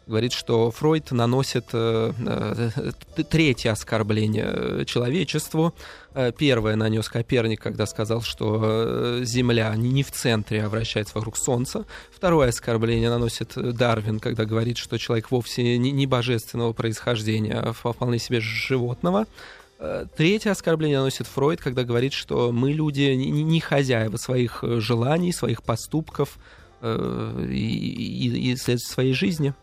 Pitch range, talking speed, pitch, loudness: 115-135 Hz, 120 wpm, 120 Hz, -24 LUFS